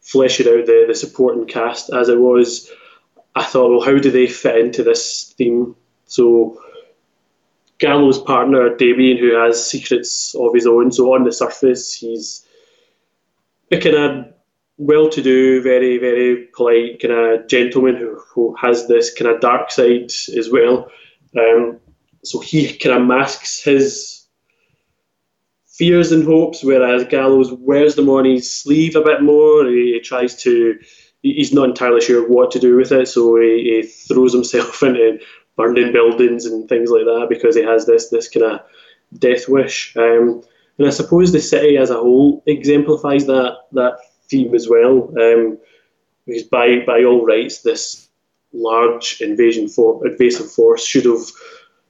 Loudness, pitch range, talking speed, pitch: -14 LUFS, 120-180 Hz, 160 wpm, 130 Hz